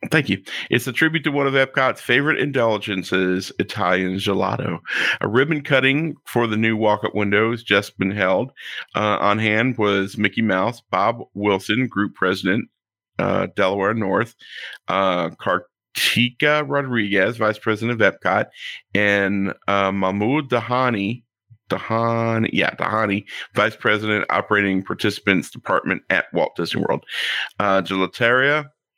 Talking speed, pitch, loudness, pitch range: 130 wpm, 105 Hz, -20 LUFS, 100-120 Hz